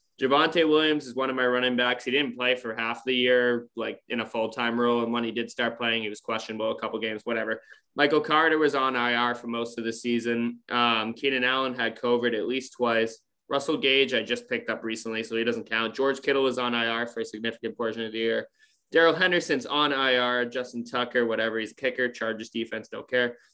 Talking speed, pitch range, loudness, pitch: 225 wpm, 115-130 Hz, -26 LUFS, 120 Hz